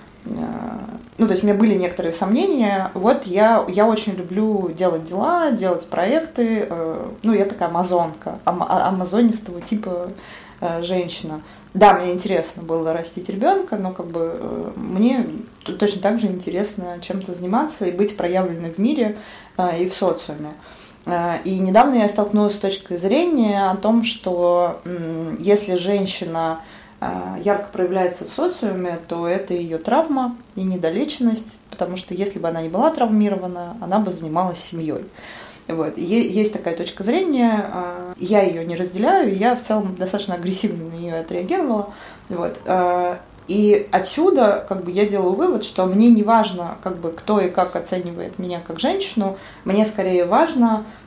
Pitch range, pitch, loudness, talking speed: 180-220 Hz, 195 Hz, -20 LUFS, 145 wpm